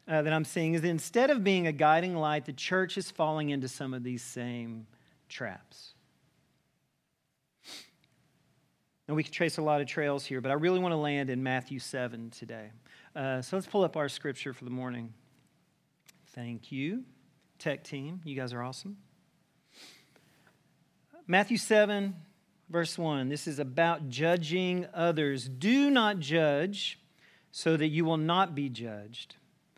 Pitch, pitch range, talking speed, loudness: 155 Hz, 135-175 Hz, 155 wpm, -31 LUFS